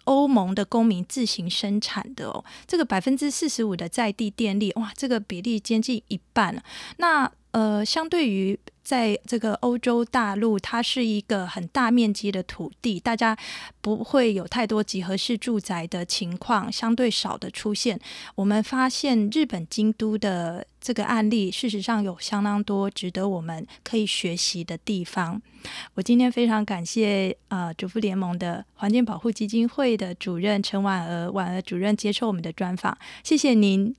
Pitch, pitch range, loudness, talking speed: 215 Hz, 195-235 Hz, -25 LUFS, 265 characters per minute